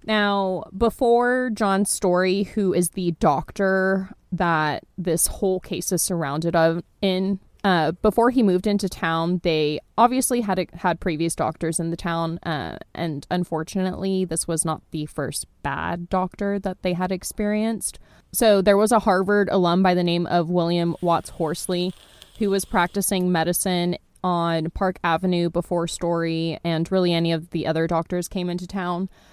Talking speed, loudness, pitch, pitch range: 160 wpm, -22 LUFS, 180 Hz, 170-195 Hz